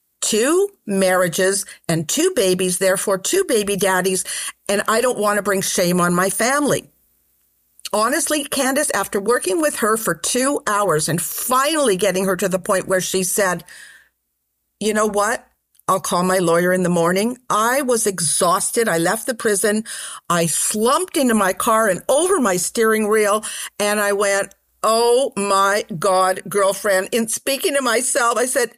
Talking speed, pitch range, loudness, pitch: 165 wpm, 185-235 Hz, -18 LUFS, 205 Hz